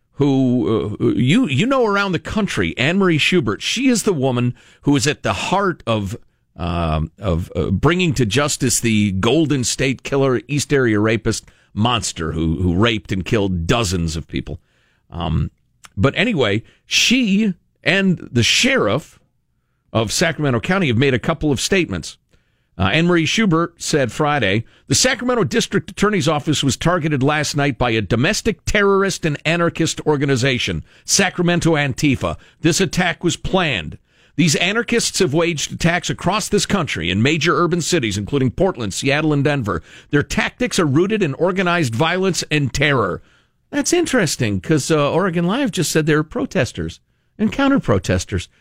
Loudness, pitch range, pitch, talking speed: -18 LUFS, 115-180 Hz, 150 Hz, 155 wpm